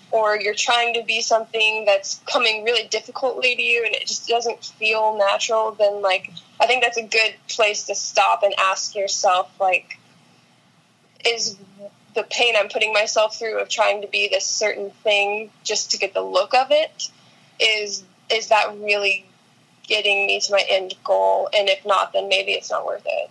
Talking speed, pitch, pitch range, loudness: 185 wpm, 215 Hz, 200-225 Hz, -19 LUFS